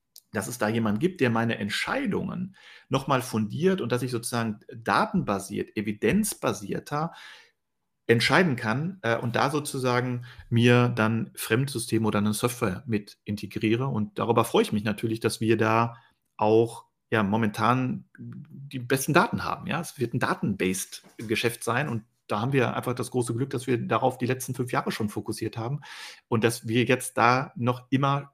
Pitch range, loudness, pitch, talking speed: 110-135 Hz, -26 LUFS, 120 Hz, 165 wpm